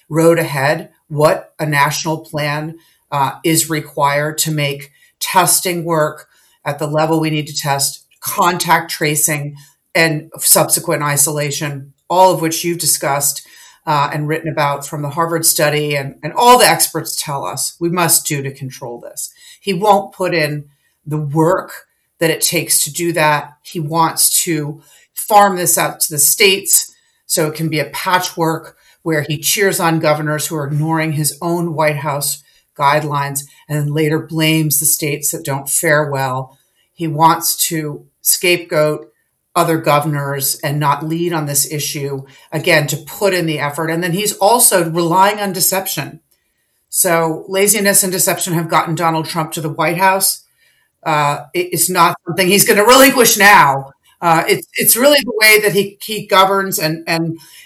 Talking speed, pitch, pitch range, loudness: 165 wpm, 160 Hz, 150-180 Hz, -14 LUFS